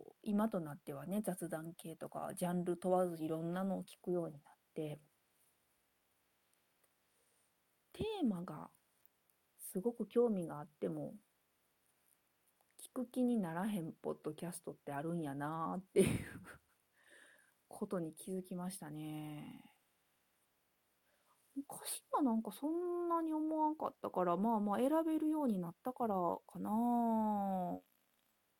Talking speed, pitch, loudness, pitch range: 250 characters per minute, 185 Hz, -40 LUFS, 160-235 Hz